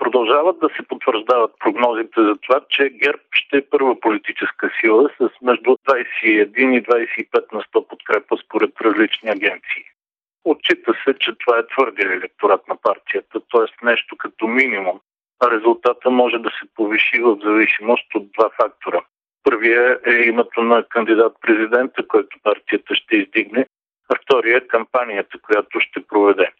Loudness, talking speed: -17 LUFS, 145 wpm